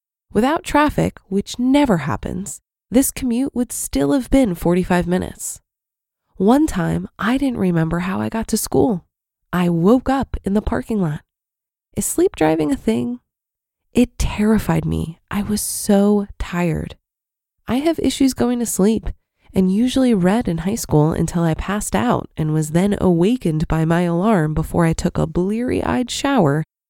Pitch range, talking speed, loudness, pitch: 170-245 Hz, 160 wpm, -19 LUFS, 200 Hz